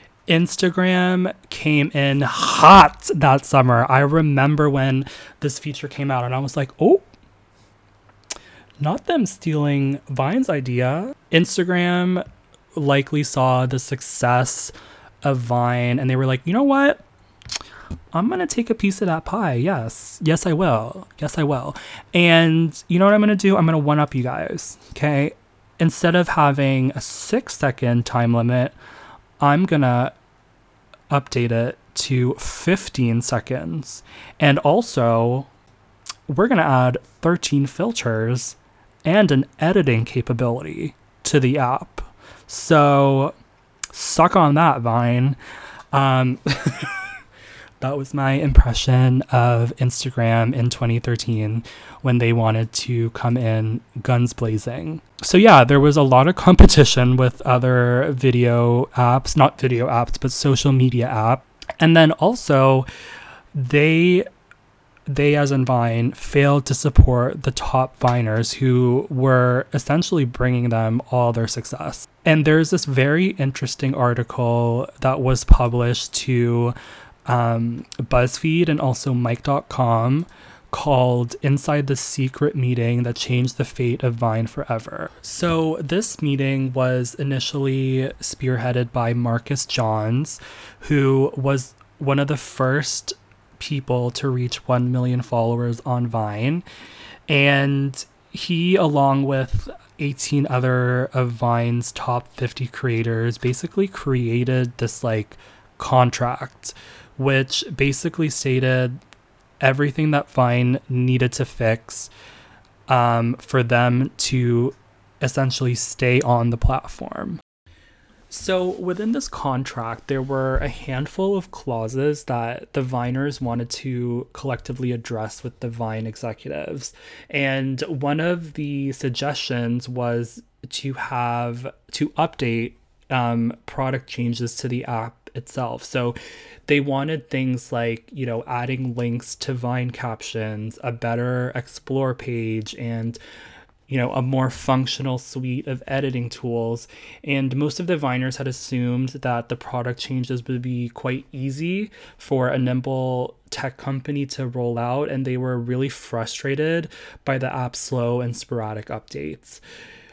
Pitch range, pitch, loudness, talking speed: 120-145 Hz, 130 Hz, -20 LUFS, 130 wpm